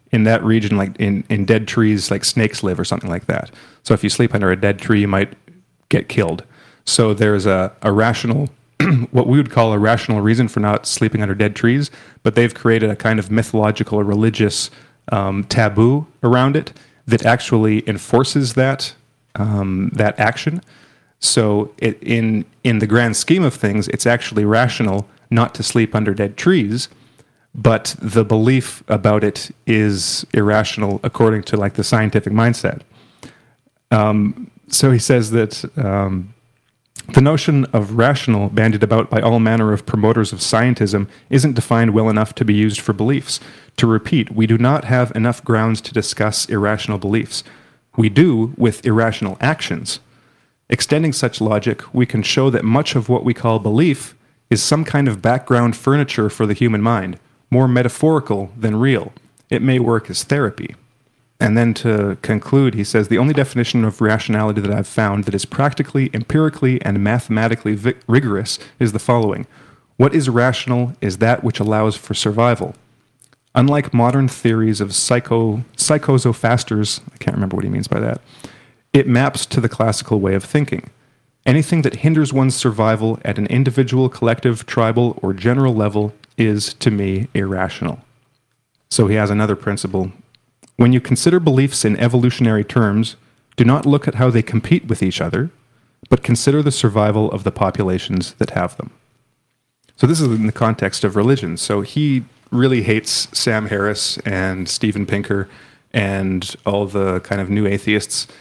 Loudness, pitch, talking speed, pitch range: -17 LUFS, 115 Hz, 165 wpm, 105-130 Hz